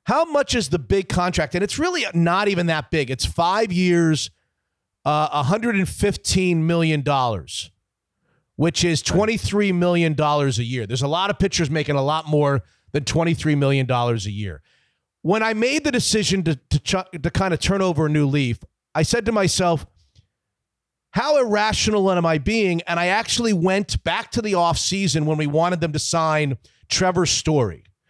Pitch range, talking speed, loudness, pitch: 140-195 Hz, 170 wpm, -20 LUFS, 165 Hz